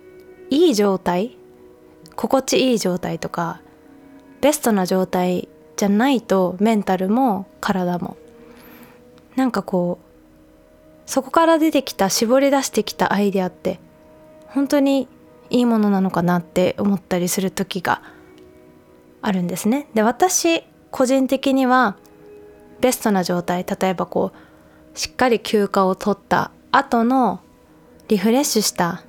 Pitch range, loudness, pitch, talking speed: 175-255 Hz, -19 LUFS, 200 Hz, 250 characters per minute